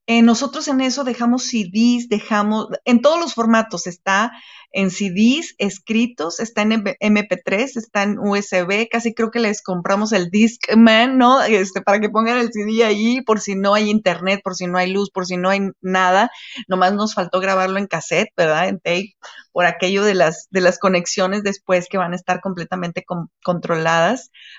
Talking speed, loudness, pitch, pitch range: 185 wpm, -18 LUFS, 200 Hz, 185-225 Hz